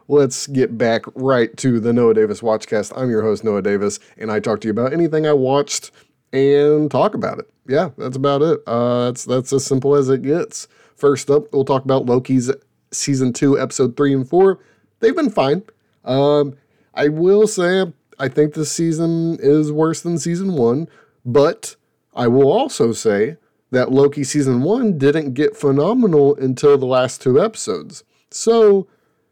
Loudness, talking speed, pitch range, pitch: -17 LUFS, 175 wpm, 130-155 Hz, 140 Hz